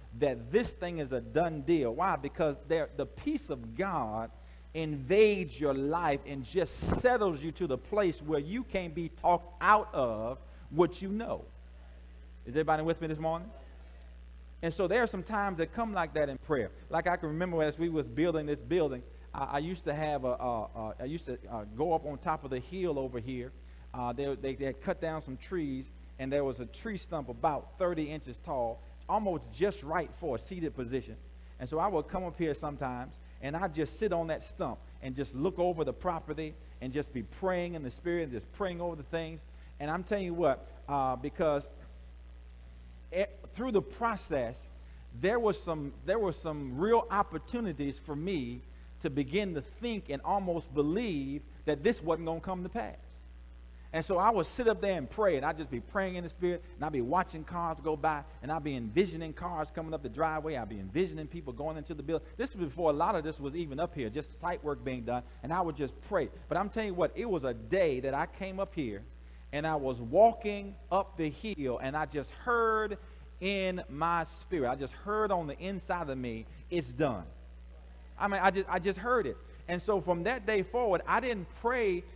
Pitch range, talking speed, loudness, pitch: 130-180 Hz, 215 wpm, -33 LUFS, 155 Hz